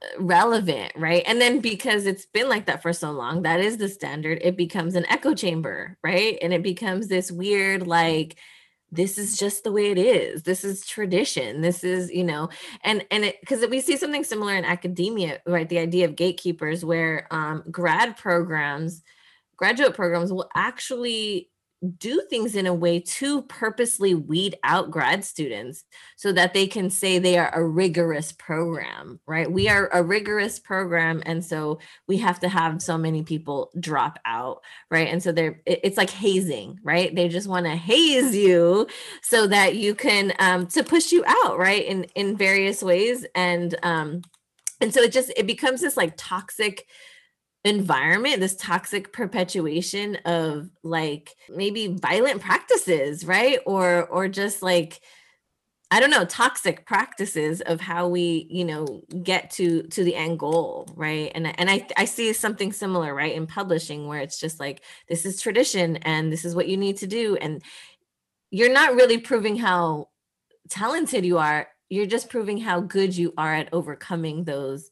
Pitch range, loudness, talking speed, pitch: 170-210 Hz, -23 LUFS, 175 wpm, 180 Hz